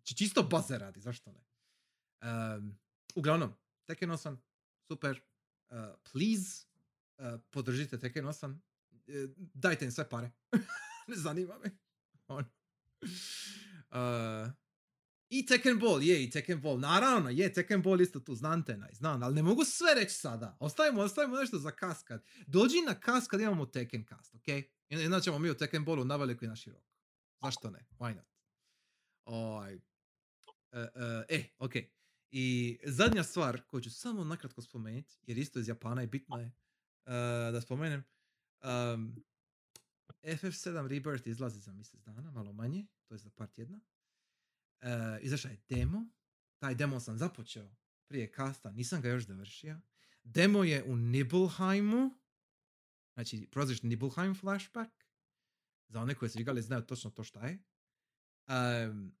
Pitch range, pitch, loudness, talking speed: 120-180 Hz, 135 Hz, -35 LUFS, 155 wpm